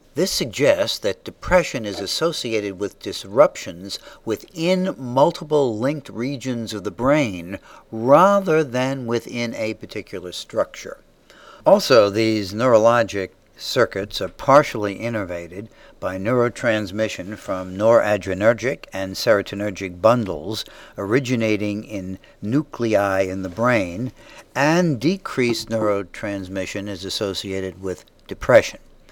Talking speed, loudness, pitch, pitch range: 100 wpm, -21 LUFS, 110 Hz, 100-125 Hz